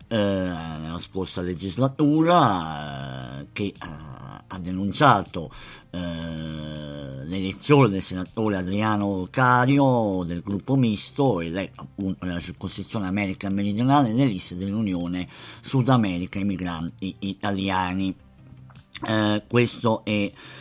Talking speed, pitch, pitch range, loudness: 100 wpm, 95 Hz, 90-110 Hz, -24 LUFS